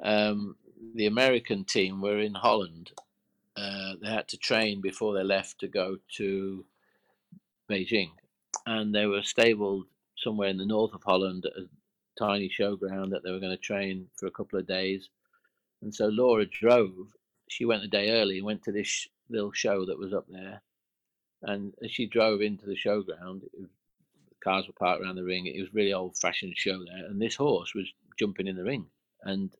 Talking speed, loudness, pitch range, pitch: 195 wpm, -29 LUFS, 95-105 Hz, 100 Hz